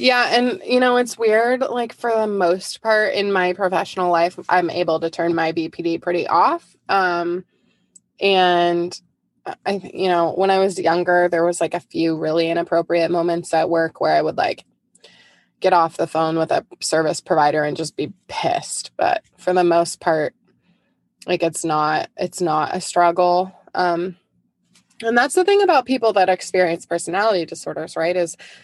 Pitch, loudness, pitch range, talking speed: 180 Hz, -19 LUFS, 170-195 Hz, 175 wpm